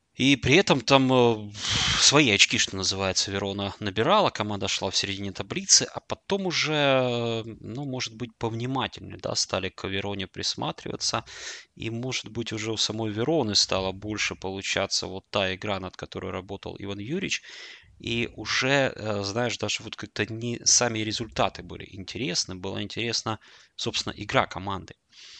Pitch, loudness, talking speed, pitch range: 110 Hz, -25 LUFS, 145 wpm, 100-120 Hz